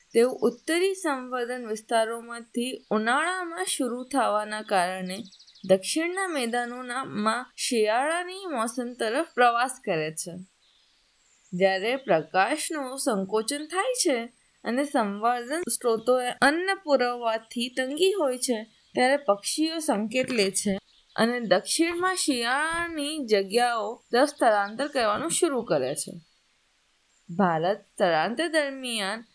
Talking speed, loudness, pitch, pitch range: 95 wpm, -26 LUFS, 245 Hz, 215-290 Hz